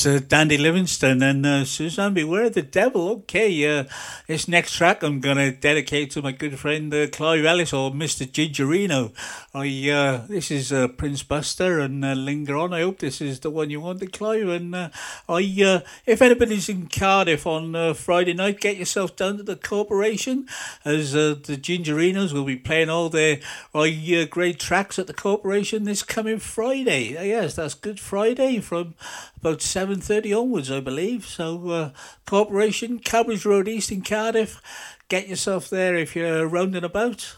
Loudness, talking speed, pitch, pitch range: -22 LUFS, 180 wpm, 170 Hz, 150-200 Hz